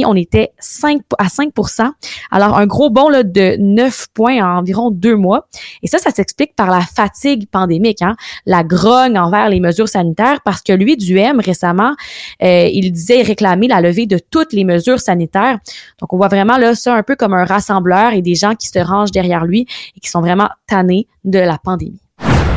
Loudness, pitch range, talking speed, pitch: -12 LUFS, 185-240 Hz, 200 wpm, 205 Hz